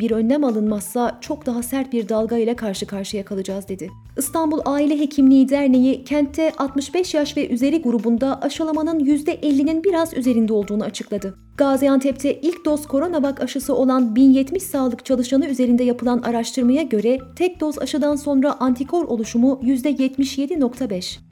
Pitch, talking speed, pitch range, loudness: 265 Hz, 140 wpm, 235-290 Hz, -19 LUFS